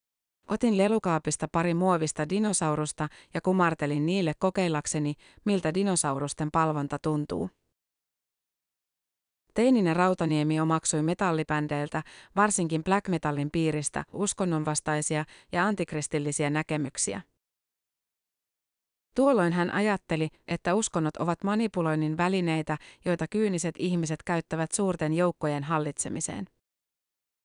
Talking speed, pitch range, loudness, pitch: 85 wpm, 155-185 Hz, -28 LUFS, 160 Hz